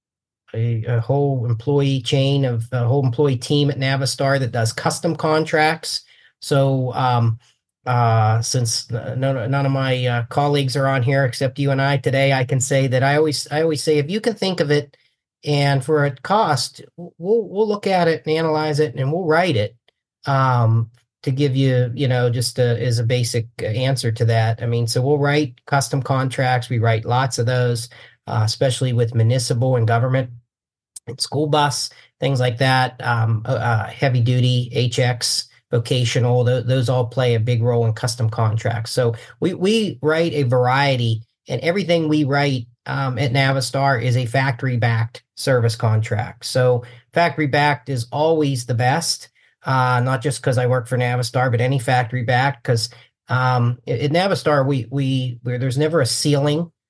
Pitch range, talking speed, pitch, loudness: 120-145 Hz, 180 wpm, 130 Hz, -19 LUFS